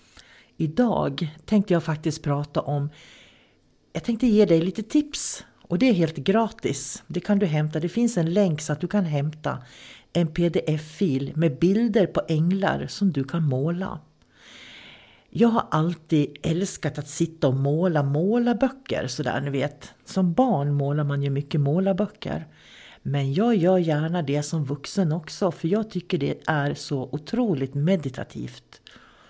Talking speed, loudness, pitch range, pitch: 155 wpm, -24 LUFS, 145-195 Hz, 165 Hz